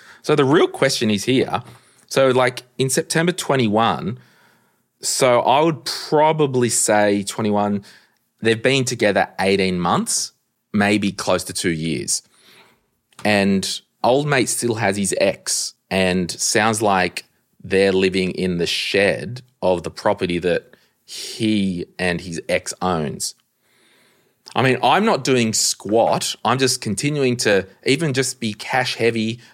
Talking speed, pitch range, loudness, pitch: 135 wpm, 95-130 Hz, -19 LUFS, 110 Hz